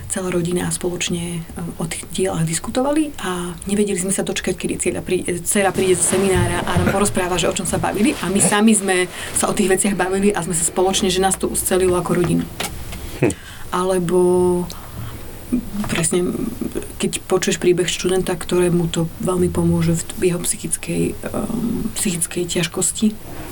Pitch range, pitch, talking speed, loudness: 175-195 Hz, 180 Hz, 160 wpm, -19 LUFS